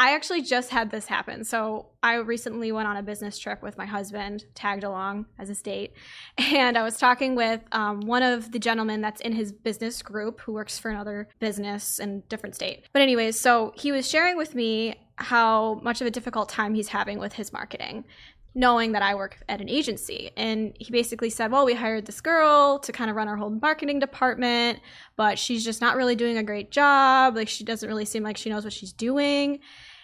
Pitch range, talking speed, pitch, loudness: 215-250 Hz, 220 wpm, 225 Hz, -25 LUFS